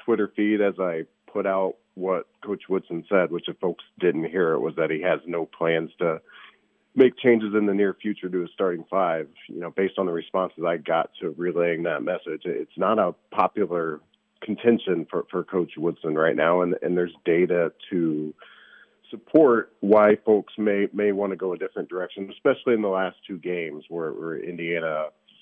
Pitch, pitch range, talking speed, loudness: 95 Hz, 85-105 Hz, 190 wpm, -24 LUFS